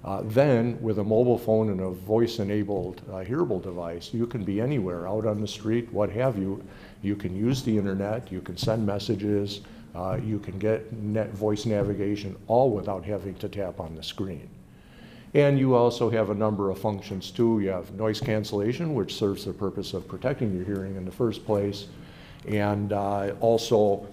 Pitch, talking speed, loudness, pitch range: 105 Hz, 190 wpm, -27 LUFS, 100-110 Hz